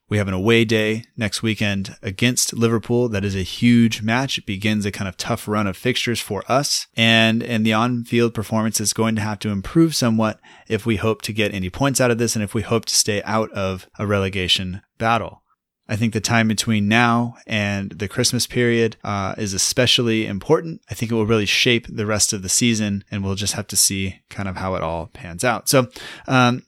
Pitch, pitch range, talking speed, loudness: 110 Hz, 100-120 Hz, 225 wpm, -19 LUFS